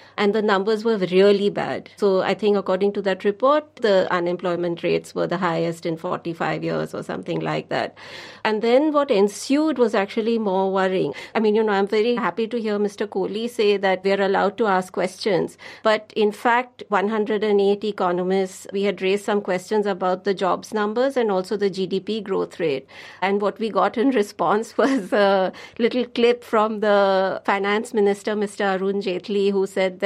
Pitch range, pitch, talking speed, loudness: 190-220 Hz, 200 Hz, 185 wpm, -21 LUFS